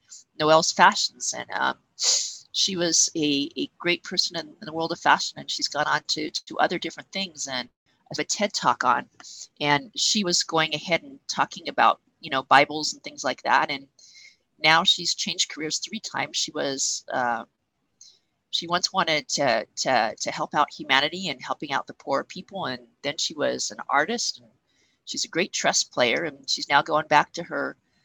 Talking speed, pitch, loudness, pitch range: 195 wpm, 160 Hz, -24 LUFS, 145-185 Hz